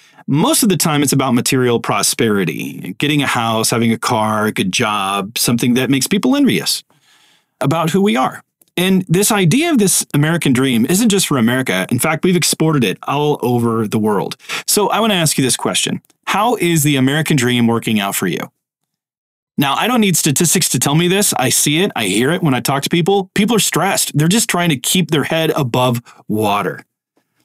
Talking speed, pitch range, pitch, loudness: 210 wpm, 125-185 Hz, 150 Hz, -14 LUFS